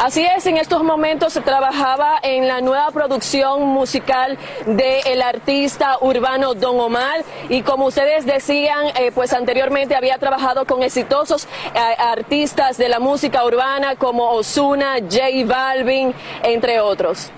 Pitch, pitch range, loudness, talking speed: 265 Hz, 255-280 Hz, -17 LUFS, 140 wpm